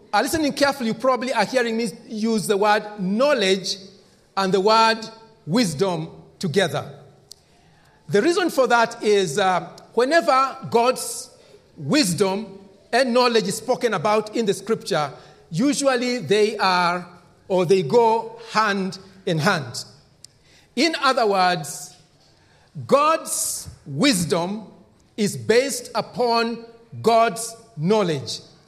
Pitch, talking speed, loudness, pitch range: 210 Hz, 110 wpm, -21 LUFS, 185-235 Hz